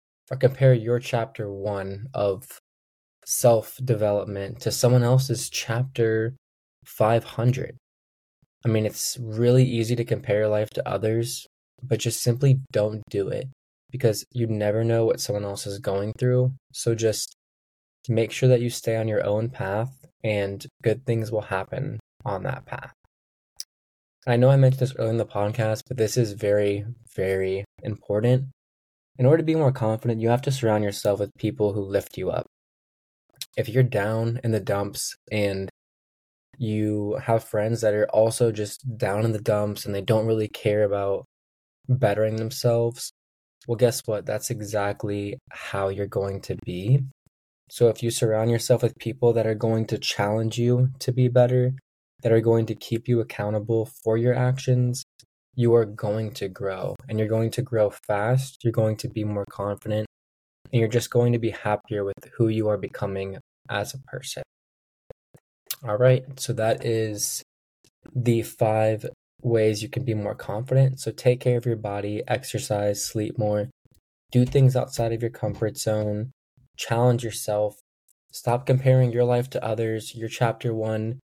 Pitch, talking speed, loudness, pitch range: 110 Hz, 165 wpm, -24 LUFS, 105-125 Hz